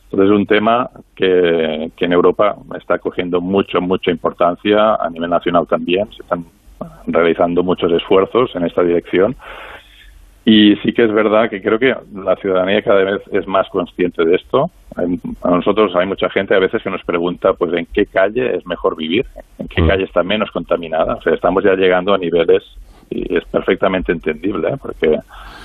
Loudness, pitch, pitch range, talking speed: -15 LUFS, 95 Hz, 90-105 Hz, 185 wpm